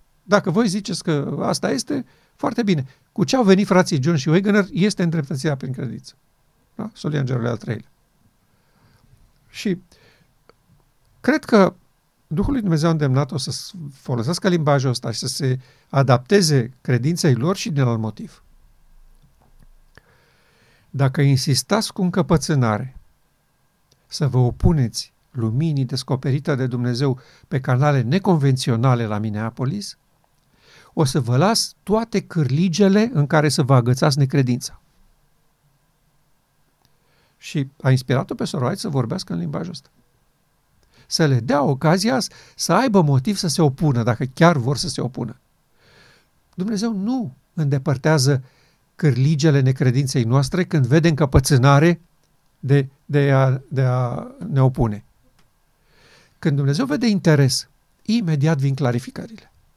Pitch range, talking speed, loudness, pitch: 130-170 Hz, 120 wpm, -20 LUFS, 145 Hz